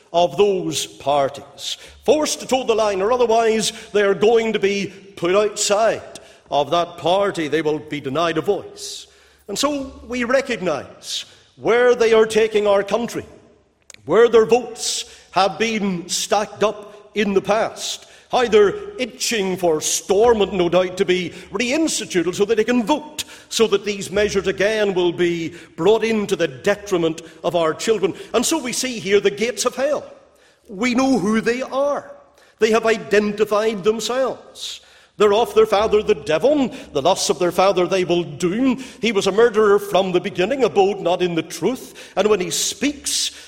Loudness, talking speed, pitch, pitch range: -19 LUFS, 170 wpm, 205 Hz, 180-230 Hz